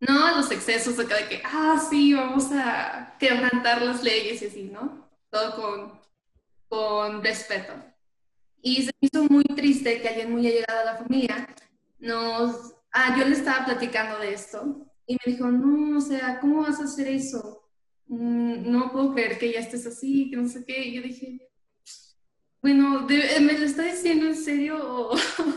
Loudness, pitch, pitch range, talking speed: -24 LUFS, 250 Hz, 230-280 Hz, 175 wpm